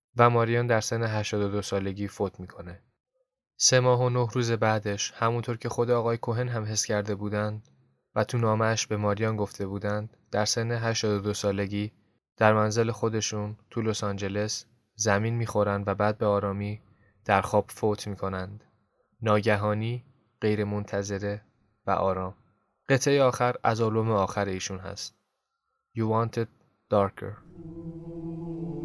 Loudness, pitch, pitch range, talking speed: -27 LUFS, 110 Hz, 105-120 Hz, 135 wpm